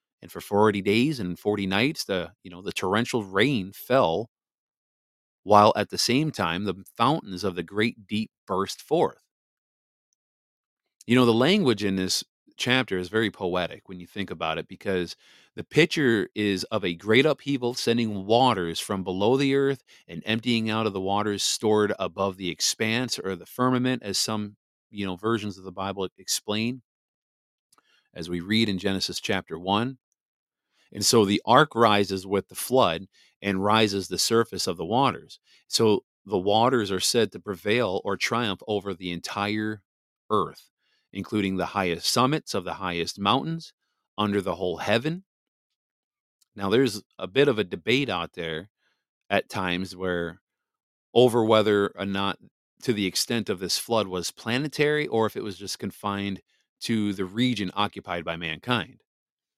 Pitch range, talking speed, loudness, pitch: 95-115 Hz, 160 wpm, -25 LUFS, 100 Hz